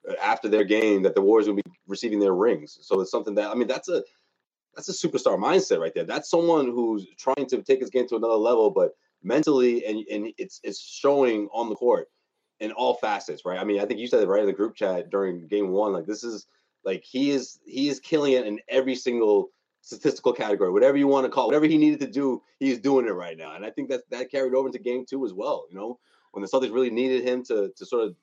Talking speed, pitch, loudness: 255 wpm, 140 Hz, -24 LUFS